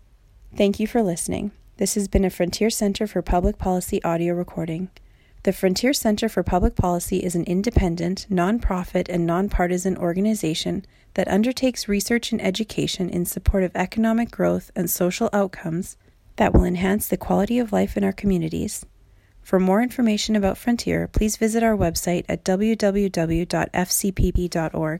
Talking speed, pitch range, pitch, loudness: 150 wpm, 175-210 Hz, 190 Hz, -22 LUFS